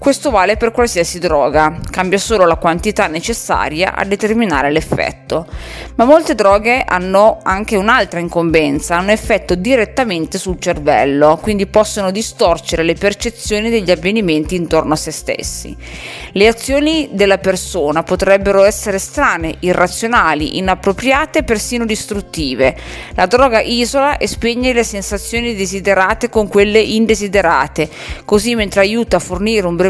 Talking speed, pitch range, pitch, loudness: 135 wpm, 175-225 Hz, 200 Hz, -13 LUFS